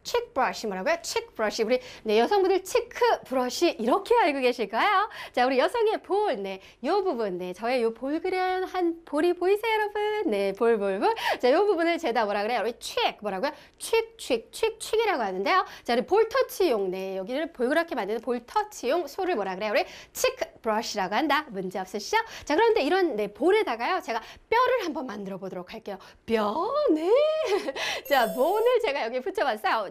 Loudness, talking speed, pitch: -26 LUFS, 375 characters per minute, 325 Hz